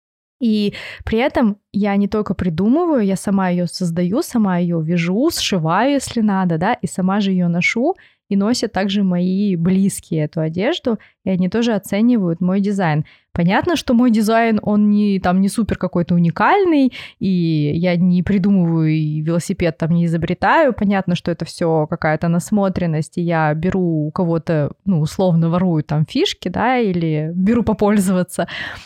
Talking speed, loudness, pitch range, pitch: 160 wpm, -17 LUFS, 170-210 Hz, 190 Hz